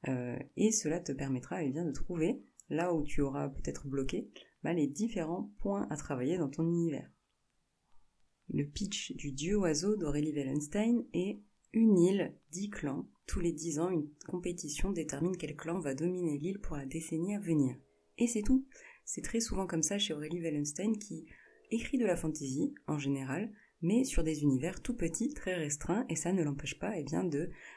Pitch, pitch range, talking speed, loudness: 165 Hz, 150-200 Hz, 190 wpm, -35 LUFS